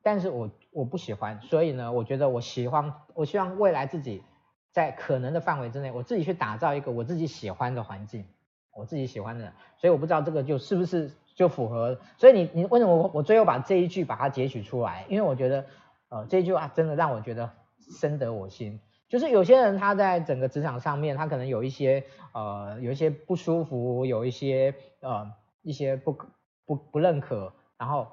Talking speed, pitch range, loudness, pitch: 320 characters per minute, 120-170 Hz, -26 LUFS, 140 Hz